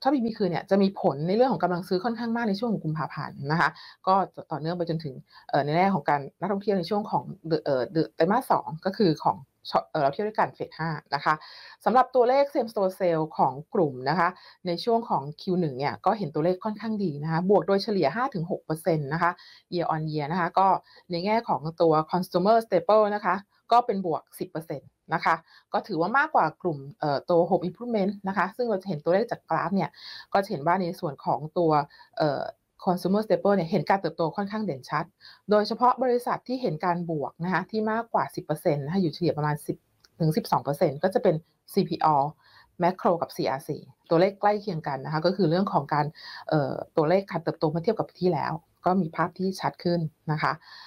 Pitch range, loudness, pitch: 160-200 Hz, -26 LUFS, 175 Hz